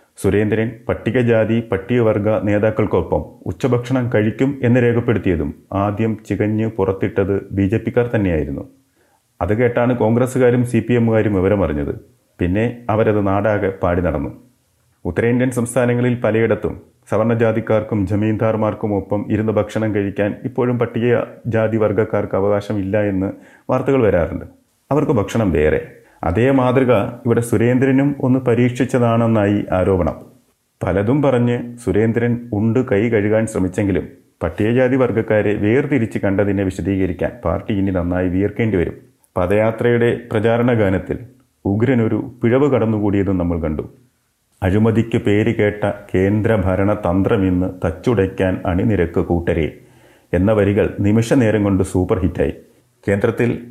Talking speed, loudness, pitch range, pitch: 110 wpm, -17 LUFS, 100-120 Hz, 110 Hz